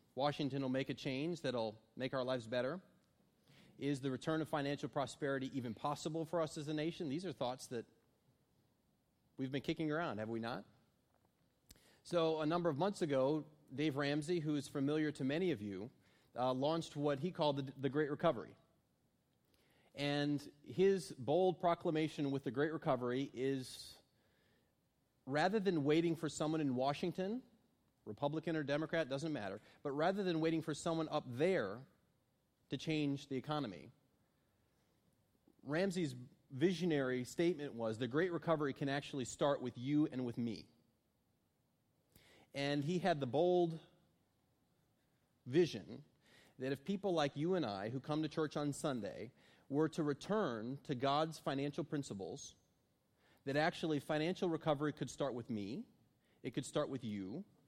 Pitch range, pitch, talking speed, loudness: 135-165 Hz, 150 Hz, 150 wpm, -39 LUFS